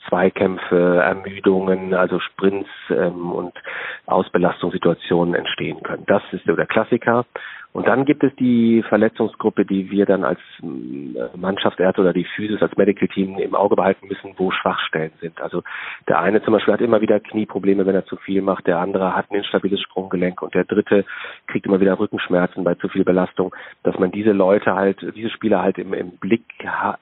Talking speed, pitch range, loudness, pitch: 180 wpm, 90-105 Hz, -19 LUFS, 95 Hz